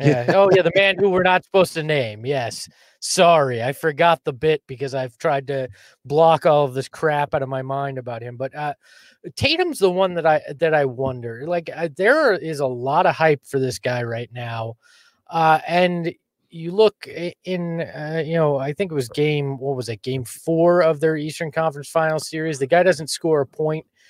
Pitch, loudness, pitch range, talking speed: 155 Hz, -20 LUFS, 135-170 Hz, 210 wpm